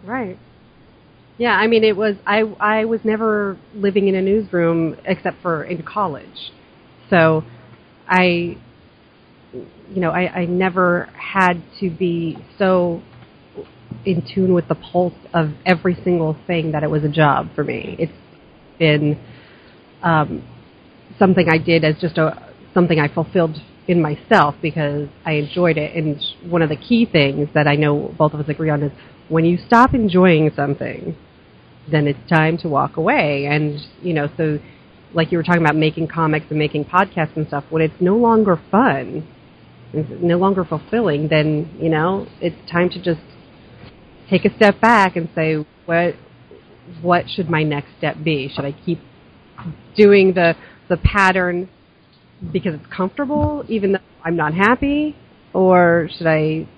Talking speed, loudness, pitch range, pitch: 160 wpm, -18 LUFS, 155-185 Hz, 170 Hz